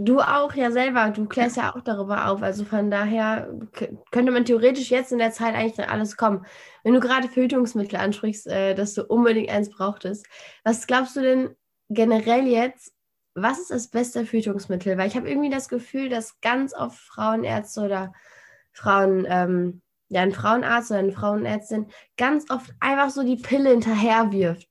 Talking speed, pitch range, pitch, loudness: 175 wpm, 205-250 Hz, 225 Hz, -23 LUFS